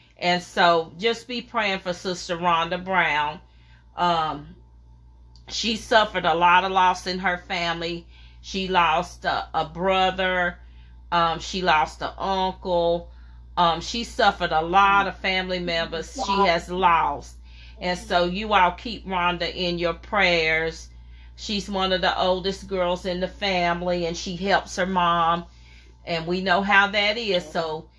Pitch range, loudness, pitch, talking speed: 165-185 Hz, -23 LUFS, 175 Hz, 150 wpm